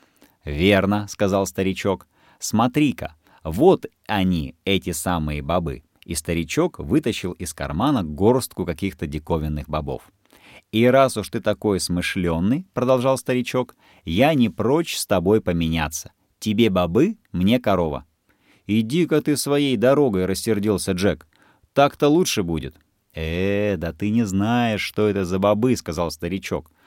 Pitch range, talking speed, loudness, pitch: 85-115 Hz, 125 wpm, -21 LUFS, 95 Hz